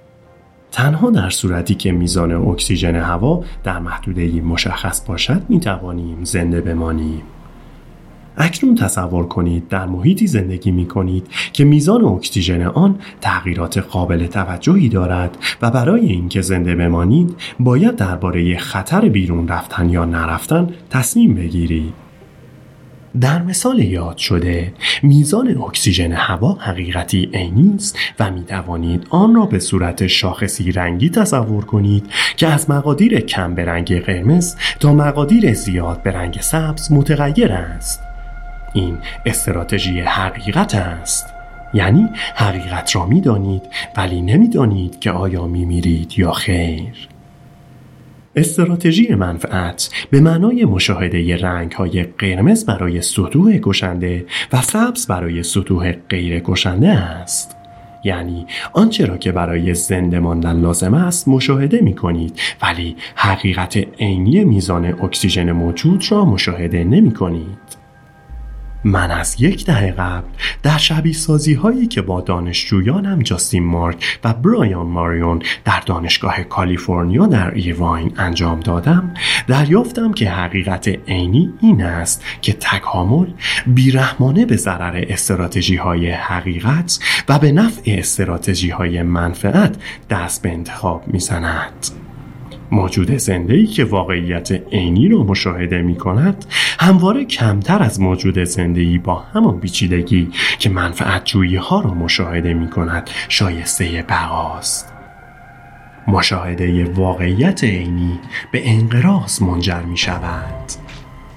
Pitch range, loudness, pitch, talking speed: 85-130 Hz, -15 LUFS, 95 Hz, 120 wpm